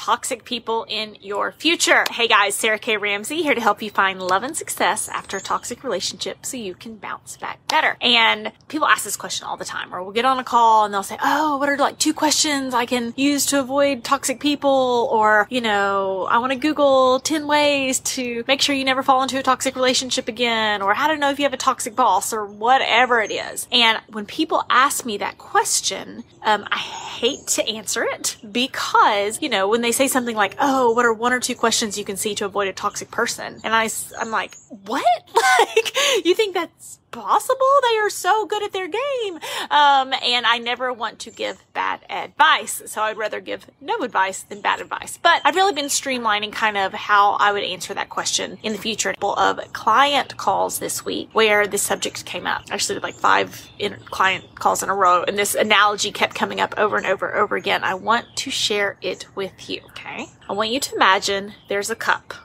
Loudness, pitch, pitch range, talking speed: -19 LUFS, 245 Hz, 210-280 Hz, 220 wpm